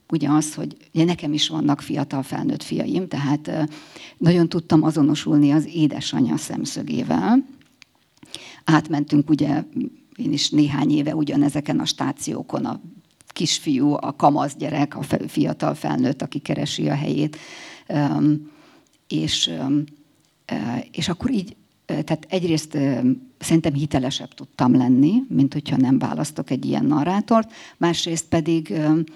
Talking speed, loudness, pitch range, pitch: 115 wpm, -21 LUFS, 145-165 Hz, 155 Hz